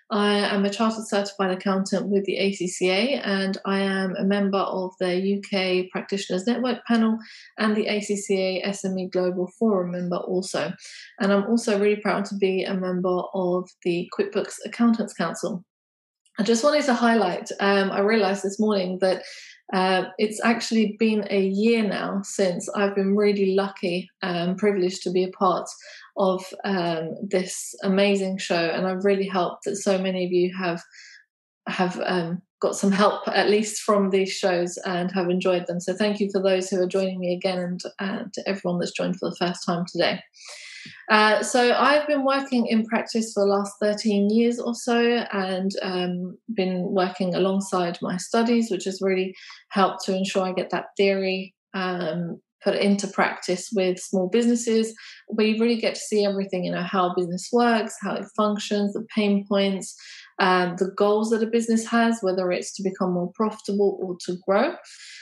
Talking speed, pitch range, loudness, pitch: 175 wpm, 185-210 Hz, -24 LUFS, 195 Hz